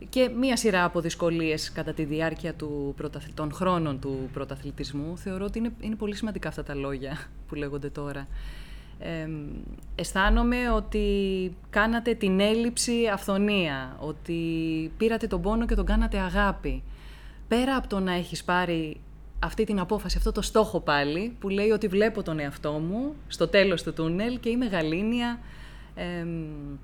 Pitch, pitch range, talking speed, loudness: 175 Hz, 155-215 Hz, 150 wpm, -28 LUFS